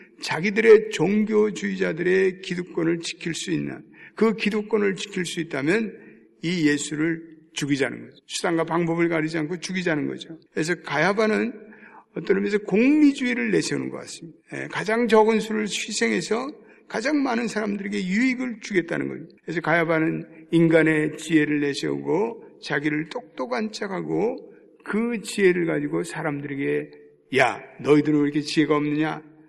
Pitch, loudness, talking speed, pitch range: 175 Hz, -23 LUFS, 340 characters per minute, 155-215 Hz